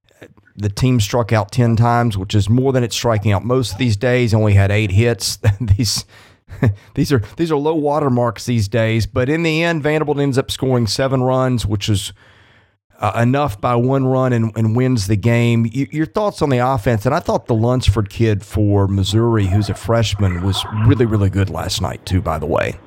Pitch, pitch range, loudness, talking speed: 115 Hz, 105-130 Hz, -17 LUFS, 205 wpm